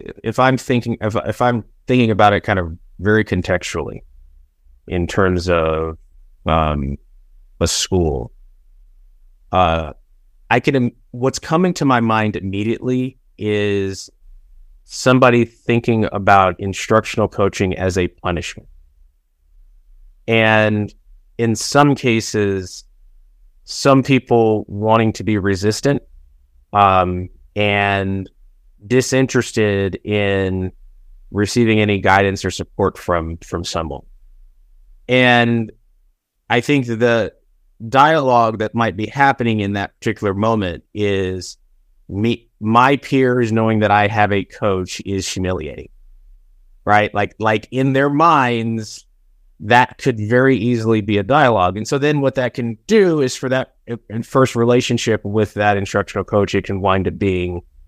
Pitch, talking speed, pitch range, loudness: 100 Hz, 125 wpm, 85-115 Hz, -17 LUFS